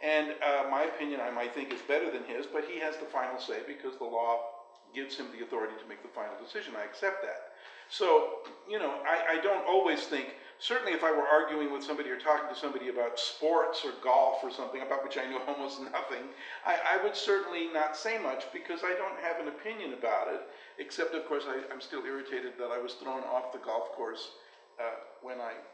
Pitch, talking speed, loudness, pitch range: 150 Hz, 225 wpm, -33 LUFS, 130-175 Hz